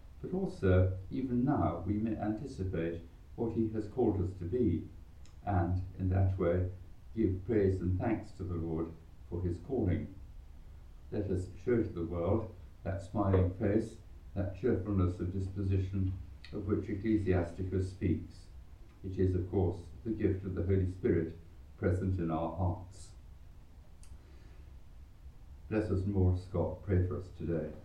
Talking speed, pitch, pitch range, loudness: 145 wpm, 95 Hz, 85-100 Hz, -34 LUFS